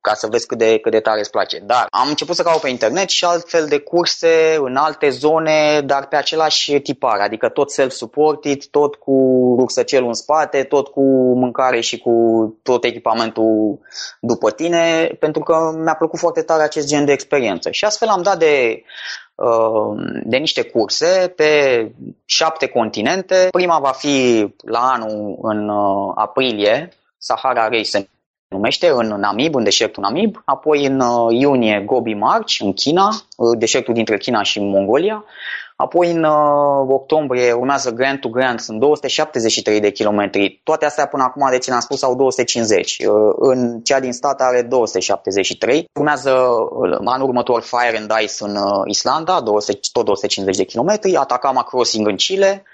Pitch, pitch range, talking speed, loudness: 135 Hz, 115-155 Hz, 155 wpm, -16 LUFS